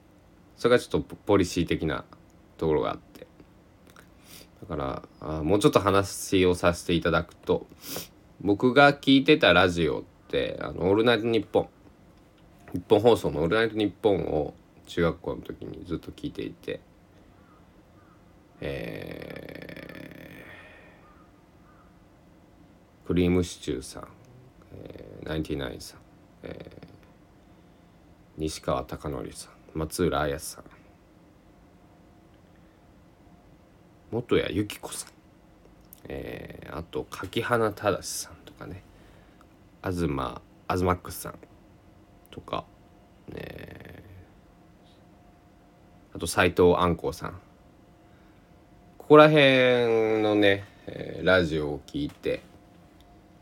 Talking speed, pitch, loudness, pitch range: 190 characters per minute, 90 Hz, -25 LUFS, 85-105 Hz